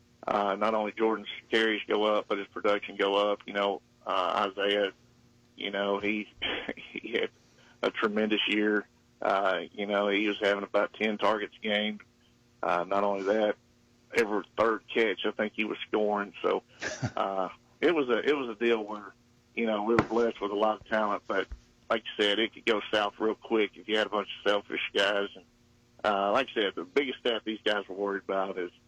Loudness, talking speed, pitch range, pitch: -29 LUFS, 205 wpm, 100-110 Hz, 105 Hz